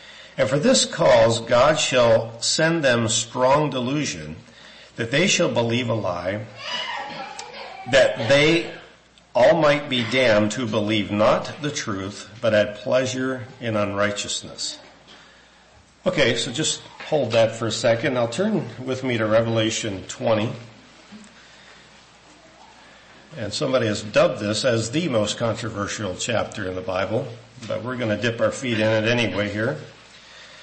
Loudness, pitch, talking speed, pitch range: -21 LUFS, 115 Hz, 140 wpm, 110-130 Hz